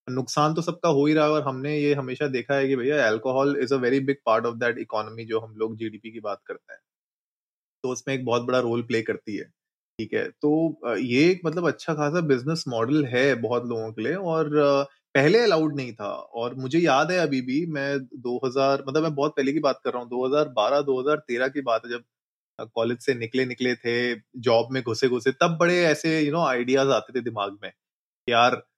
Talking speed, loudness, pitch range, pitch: 215 wpm, -24 LUFS, 120-150 Hz, 130 Hz